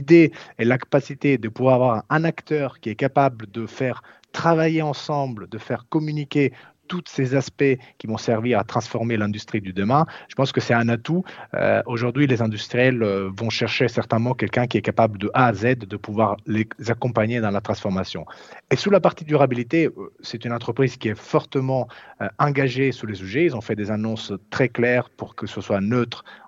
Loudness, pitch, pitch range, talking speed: -22 LUFS, 120 Hz, 110-140 Hz, 195 wpm